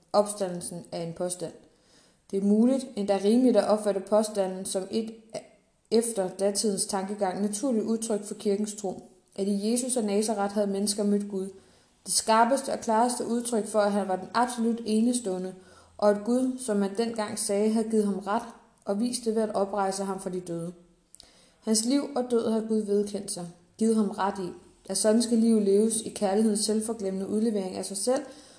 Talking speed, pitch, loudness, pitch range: 185 wpm, 210 Hz, -27 LUFS, 195-225 Hz